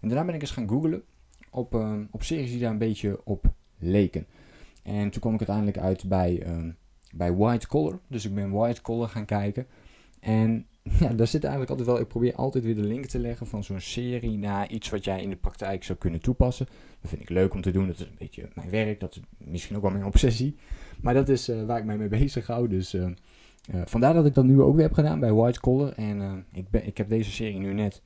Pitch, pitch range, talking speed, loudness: 110 Hz, 95-120 Hz, 250 wpm, -27 LUFS